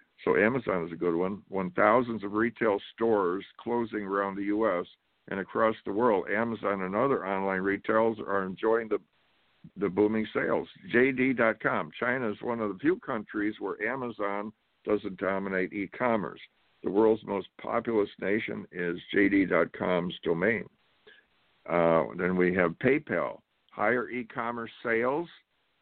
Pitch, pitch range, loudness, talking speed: 100 Hz, 95-110 Hz, -29 LUFS, 135 wpm